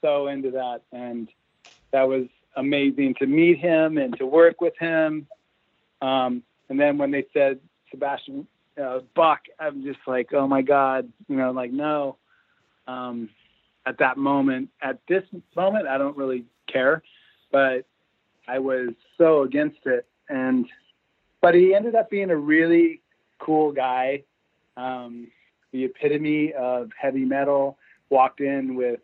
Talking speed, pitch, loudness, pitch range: 145 wpm, 140 Hz, -23 LUFS, 130-165 Hz